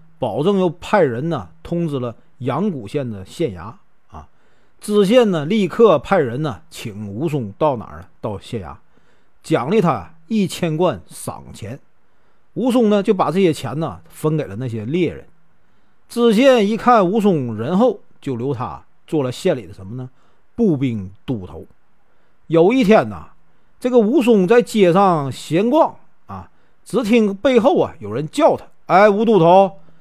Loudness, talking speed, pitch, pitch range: -17 LUFS, 220 characters per minute, 170 Hz, 130-210 Hz